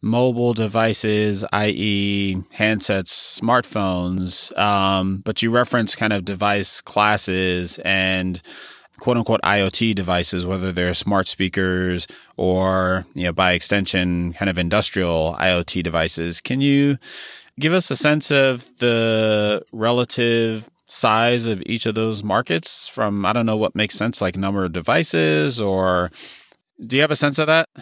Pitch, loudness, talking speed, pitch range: 100 Hz, -19 LUFS, 140 wpm, 90-115 Hz